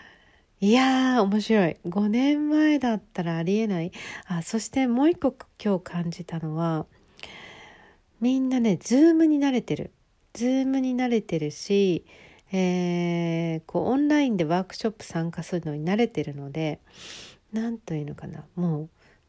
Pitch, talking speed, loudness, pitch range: 195 Hz, 290 characters per minute, -25 LUFS, 170-250 Hz